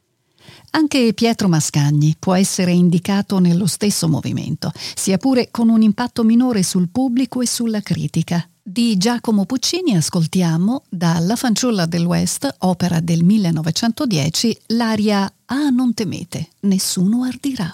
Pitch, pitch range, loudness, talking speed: 195 Hz, 170-235 Hz, -17 LUFS, 130 wpm